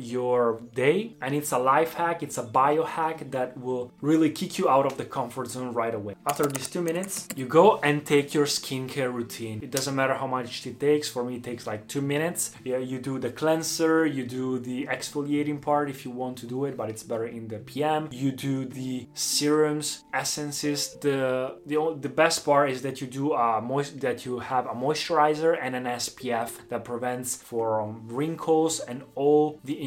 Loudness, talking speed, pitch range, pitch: -27 LUFS, 200 wpm, 125-150 Hz, 135 Hz